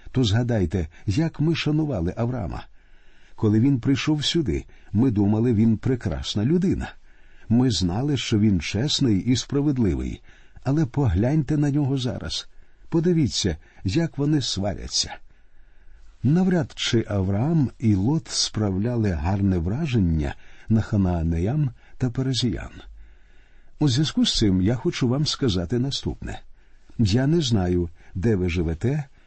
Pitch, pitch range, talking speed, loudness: 115 Hz, 95-140 Hz, 120 wpm, -23 LUFS